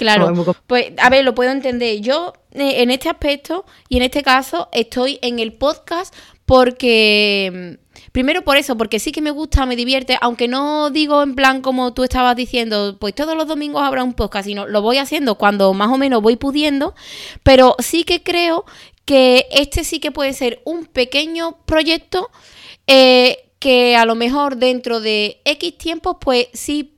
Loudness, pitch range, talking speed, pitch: -15 LUFS, 240-300 Hz, 180 wpm, 260 Hz